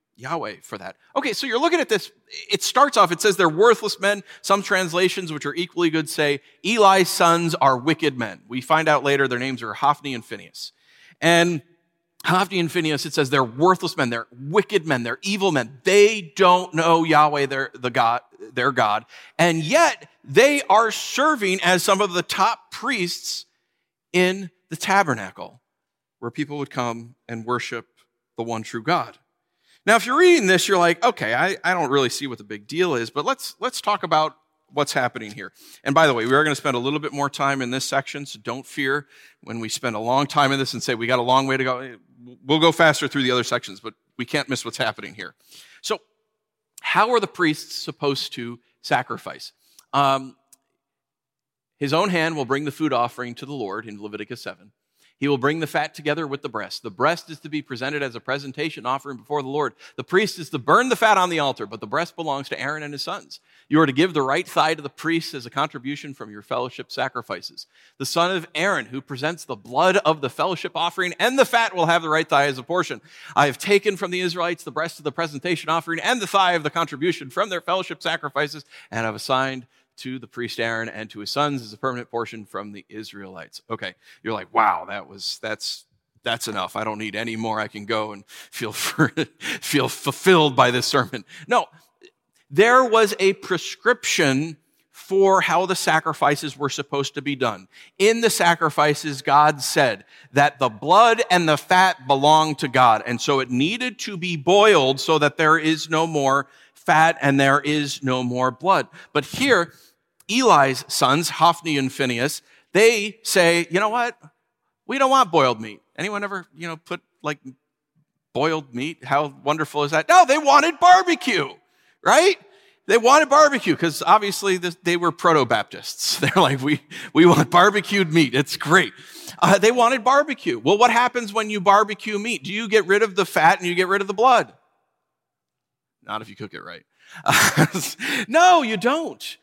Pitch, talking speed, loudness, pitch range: 155 Hz, 200 wpm, -20 LUFS, 135-190 Hz